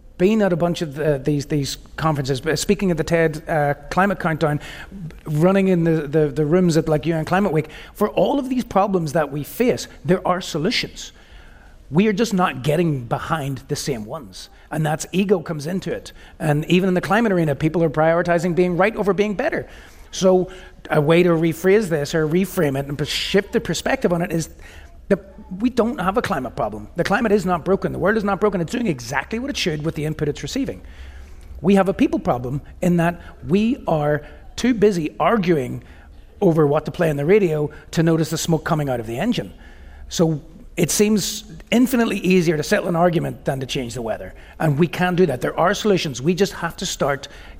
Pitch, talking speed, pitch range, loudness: 170 Hz, 210 wpm, 150-190 Hz, -20 LUFS